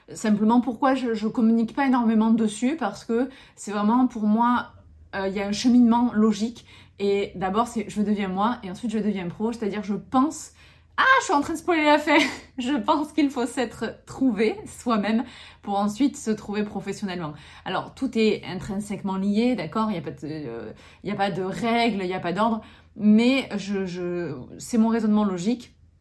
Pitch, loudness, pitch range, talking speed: 220 Hz, -24 LUFS, 200-245 Hz, 190 wpm